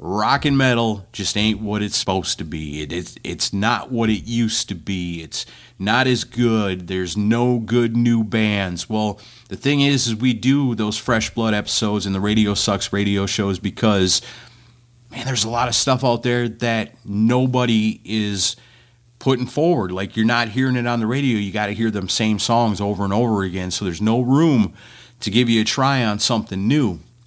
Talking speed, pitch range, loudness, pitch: 200 wpm, 100-120 Hz, -19 LUFS, 110 Hz